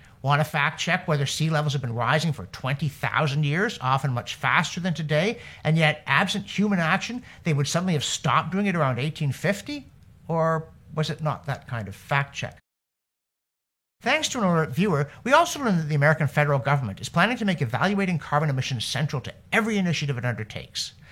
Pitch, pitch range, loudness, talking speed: 155 Hz, 140-180 Hz, -24 LUFS, 190 wpm